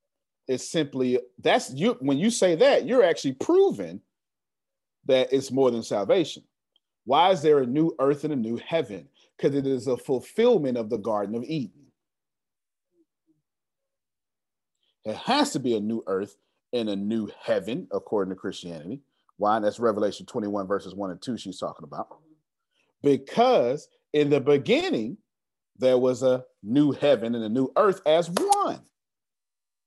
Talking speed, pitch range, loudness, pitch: 155 wpm, 125-195 Hz, -25 LUFS, 140 Hz